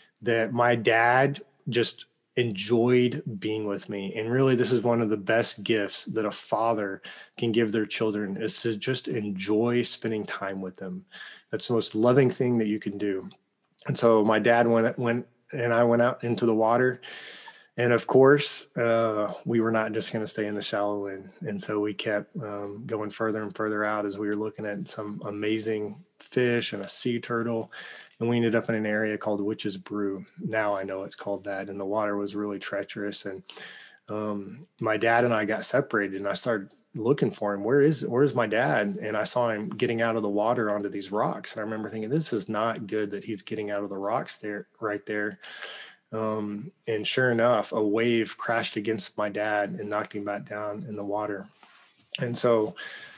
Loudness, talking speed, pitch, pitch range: -27 LUFS, 205 wpm, 110 Hz, 105-120 Hz